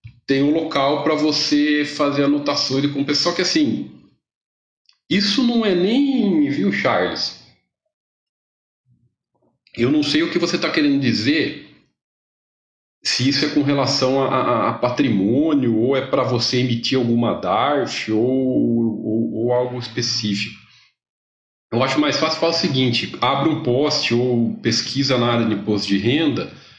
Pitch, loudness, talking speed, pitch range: 135 Hz, -19 LUFS, 150 wpm, 115-155 Hz